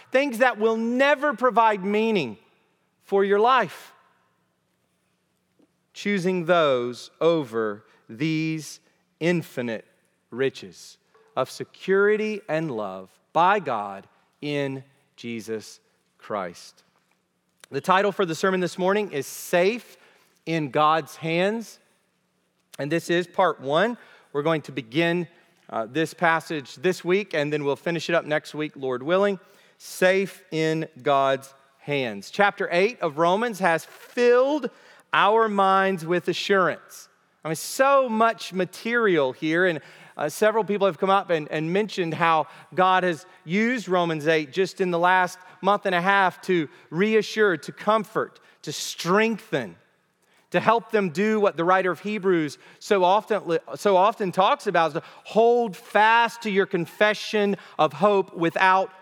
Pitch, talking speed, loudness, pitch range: 185 Hz, 135 wpm, -23 LUFS, 160-205 Hz